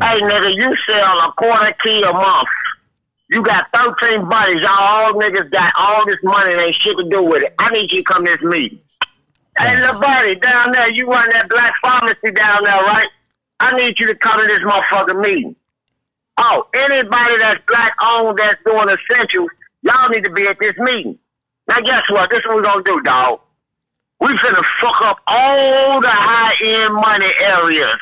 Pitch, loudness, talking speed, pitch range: 220 Hz, -12 LUFS, 195 wpm, 205-245 Hz